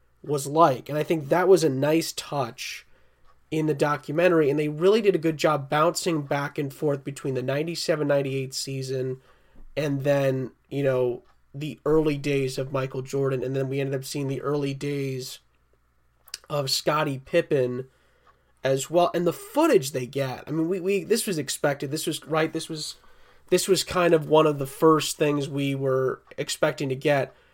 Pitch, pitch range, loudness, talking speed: 145 Hz, 135-160 Hz, -25 LUFS, 185 wpm